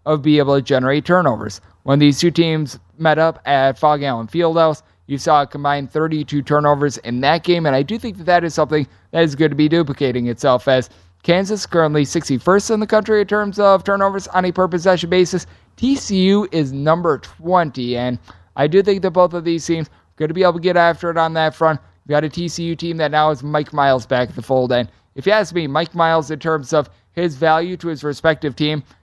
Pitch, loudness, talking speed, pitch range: 155 Hz, -17 LUFS, 230 wpm, 140-175 Hz